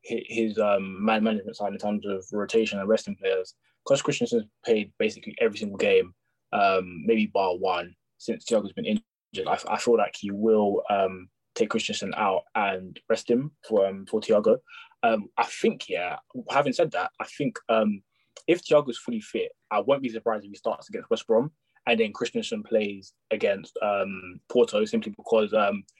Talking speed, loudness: 180 wpm, -26 LUFS